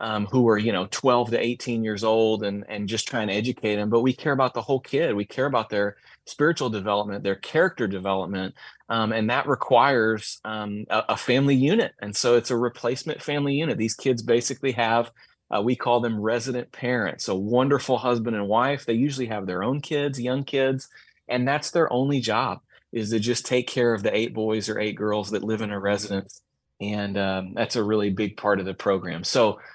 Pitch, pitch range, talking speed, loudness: 115 Hz, 105-125 Hz, 210 wpm, -24 LUFS